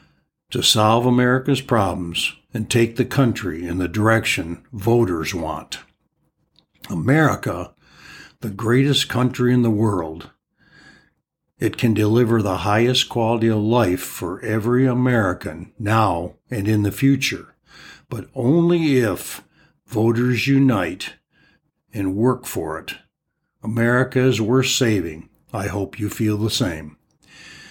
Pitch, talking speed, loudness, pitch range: 115 Hz, 120 wpm, -19 LUFS, 105-125 Hz